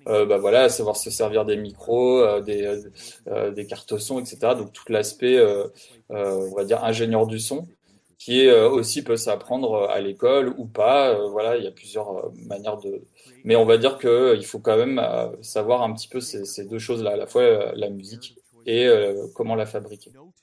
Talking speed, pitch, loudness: 205 wpm, 155 Hz, -21 LUFS